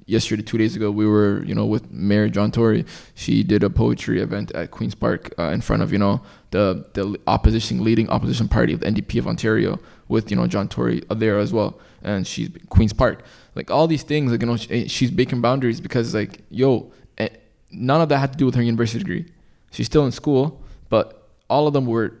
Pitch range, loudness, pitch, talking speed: 105-130 Hz, -21 LUFS, 115 Hz, 220 wpm